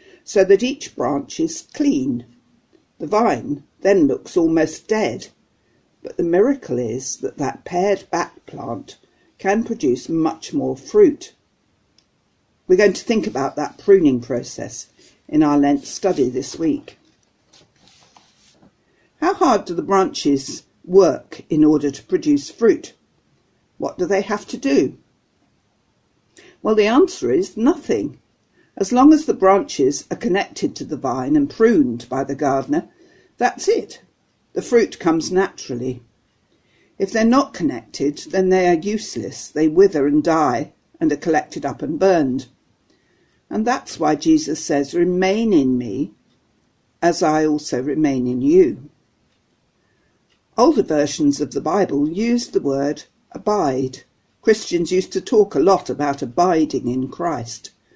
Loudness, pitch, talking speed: -19 LUFS, 195 Hz, 140 wpm